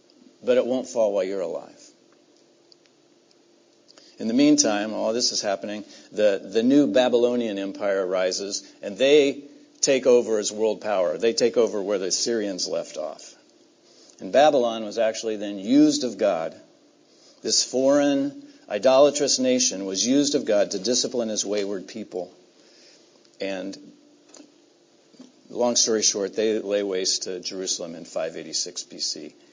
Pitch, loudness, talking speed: 225 Hz, -23 LUFS, 140 wpm